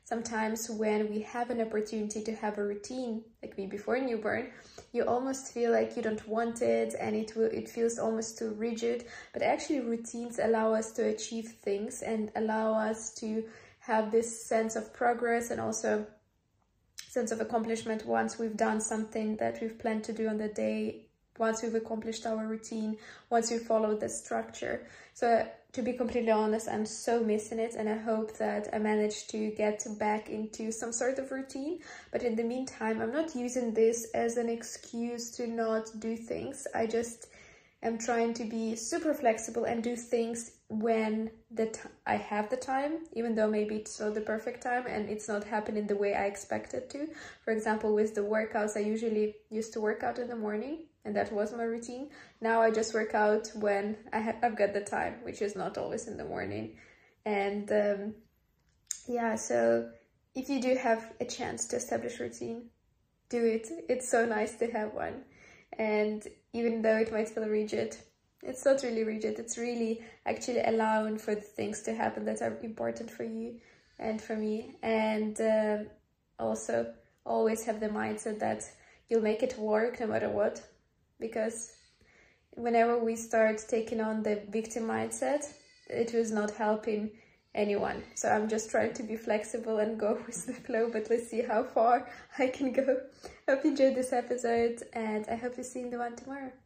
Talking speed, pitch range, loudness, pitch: 185 wpm, 215-235 Hz, -33 LUFS, 225 Hz